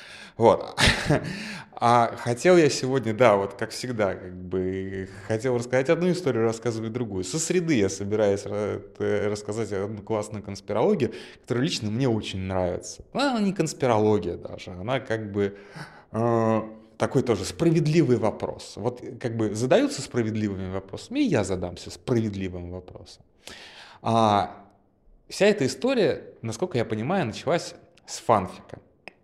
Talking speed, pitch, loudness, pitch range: 130 wpm, 110 Hz, -25 LUFS, 100-125 Hz